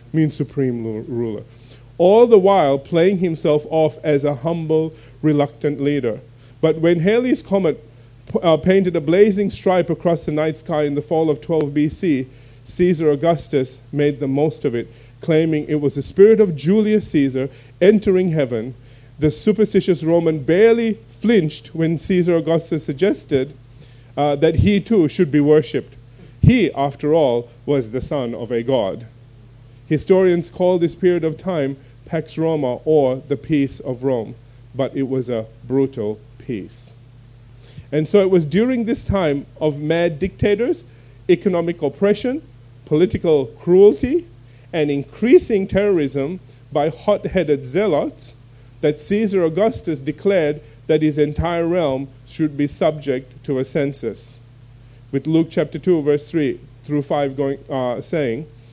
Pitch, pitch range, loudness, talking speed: 150 Hz, 125-170 Hz, -18 LUFS, 140 wpm